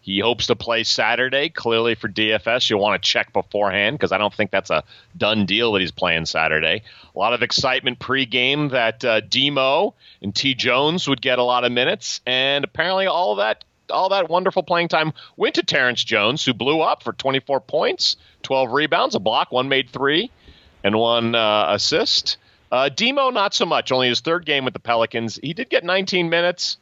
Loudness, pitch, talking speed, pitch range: -19 LUFS, 125 Hz, 200 wpm, 110-145 Hz